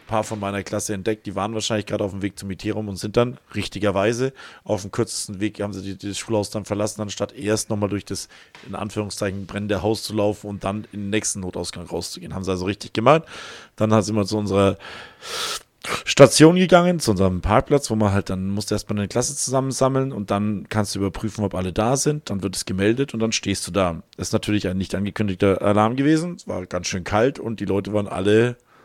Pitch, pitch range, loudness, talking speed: 105 Hz, 100-110 Hz, -22 LUFS, 230 wpm